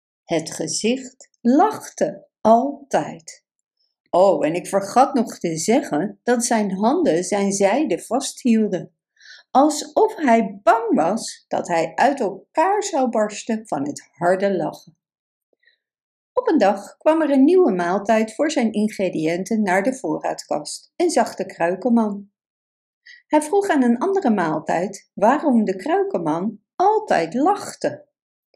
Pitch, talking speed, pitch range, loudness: 230 Hz, 125 wpm, 195-290 Hz, -20 LUFS